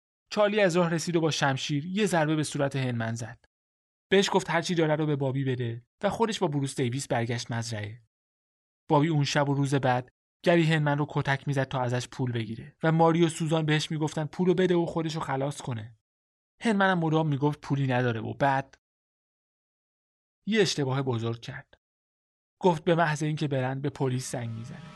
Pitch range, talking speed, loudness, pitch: 125-165 Hz, 185 wpm, -27 LUFS, 145 Hz